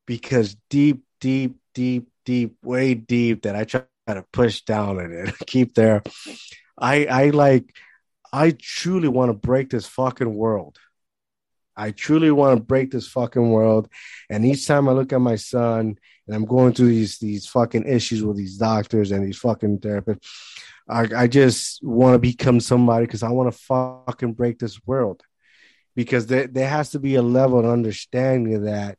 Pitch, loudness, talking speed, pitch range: 120 Hz, -20 LUFS, 180 wpm, 110-130 Hz